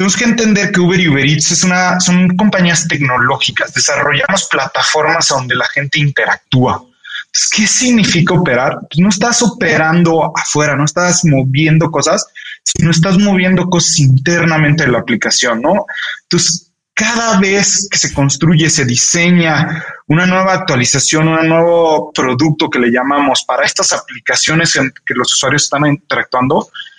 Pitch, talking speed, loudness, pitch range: 170 Hz, 145 wpm, -11 LUFS, 150-190 Hz